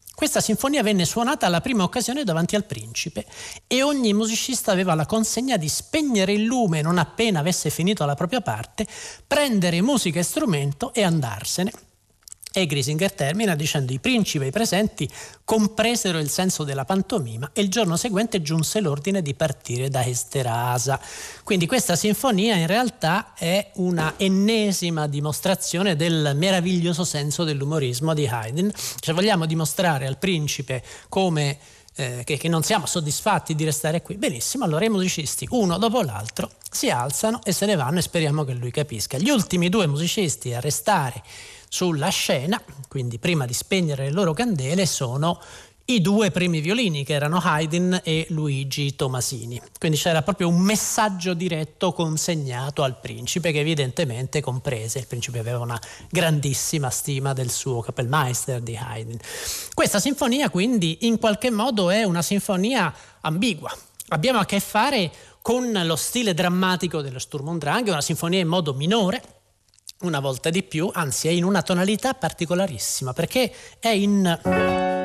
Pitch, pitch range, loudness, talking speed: 170 Hz, 140-200 Hz, -23 LUFS, 155 wpm